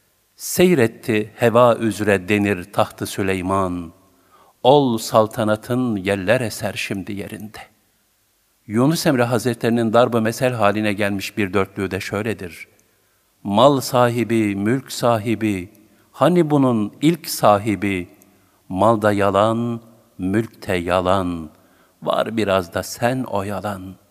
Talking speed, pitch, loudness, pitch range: 100 wpm, 105 Hz, -19 LUFS, 100-115 Hz